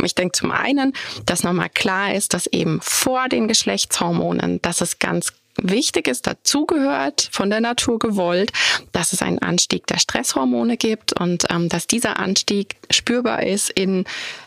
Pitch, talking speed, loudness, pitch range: 210 Hz, 160 wpm, -19 LUFS, 175-245 Hz